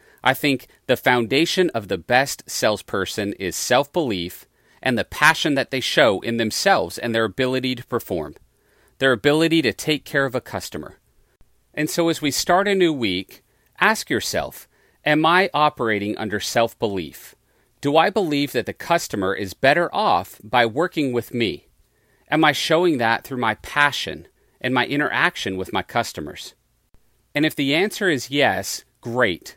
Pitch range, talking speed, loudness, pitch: 120-155 Hz, 165 wpm, -20 LUFS, 135 Hz